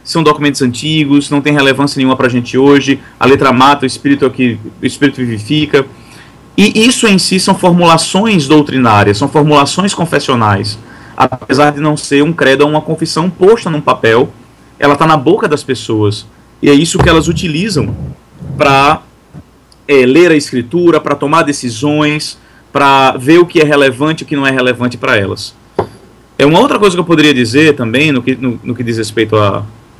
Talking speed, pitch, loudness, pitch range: 185 wpm, 145 Hz, -10 LUFS, 130-155 Hz